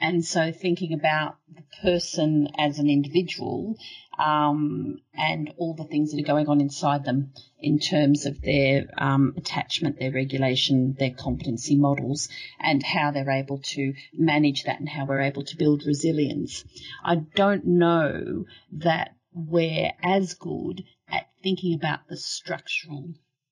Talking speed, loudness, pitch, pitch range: 145 wpm, -25 LUFS, 150 Hz, 140-165 Hz